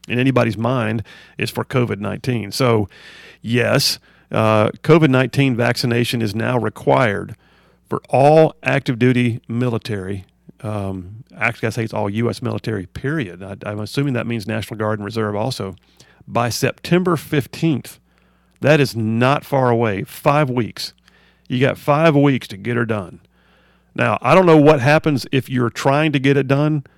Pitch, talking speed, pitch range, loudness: 120 Hz, 160 wpm, 110-140 Hz, -18 LUFS